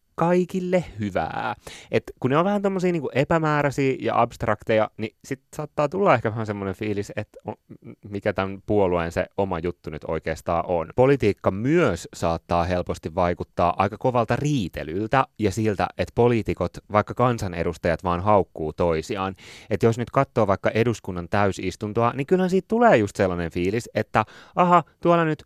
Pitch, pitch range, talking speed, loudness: 110 Hz, 95-140 Hz, 150 wpm, -23 LUFS